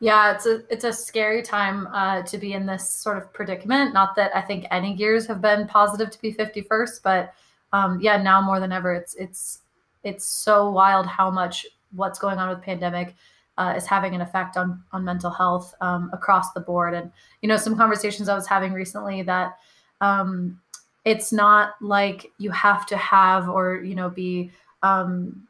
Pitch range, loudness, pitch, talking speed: 185-210 Hz, -22 LUFS, 195 Hz, 195 wpm